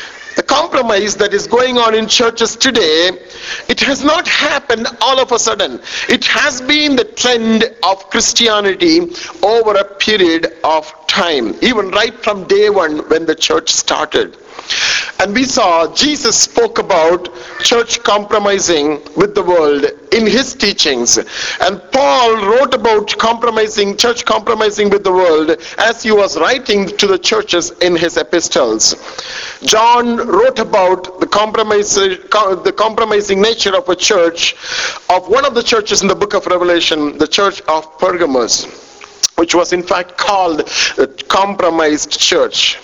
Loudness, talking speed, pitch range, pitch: -12 LUFS, 145 wpm, 180-240 Hz, 210 Hz